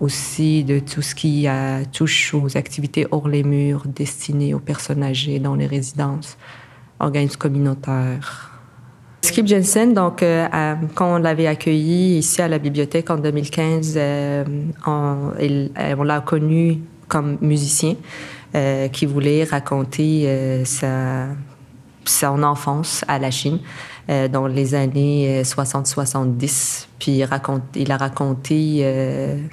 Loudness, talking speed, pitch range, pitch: -19 LUFS, 135 wpm, 135-155 Hz, 145 Hz